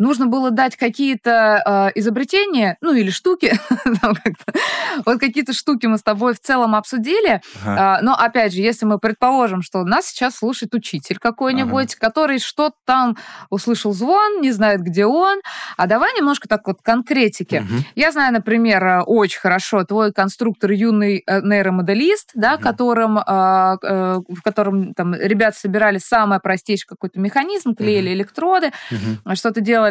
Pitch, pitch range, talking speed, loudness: 225 Hz, 200-260 Hz, 130 wpm, -17 LUFS